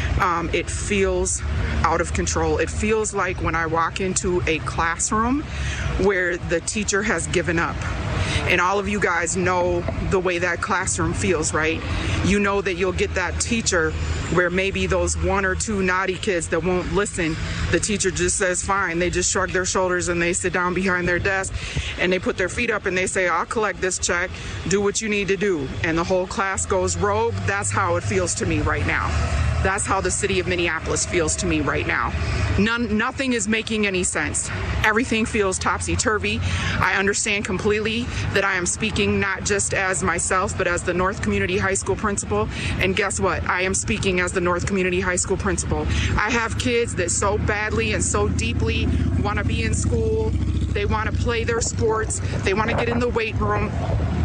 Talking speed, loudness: 200 wpm, -21 LUFS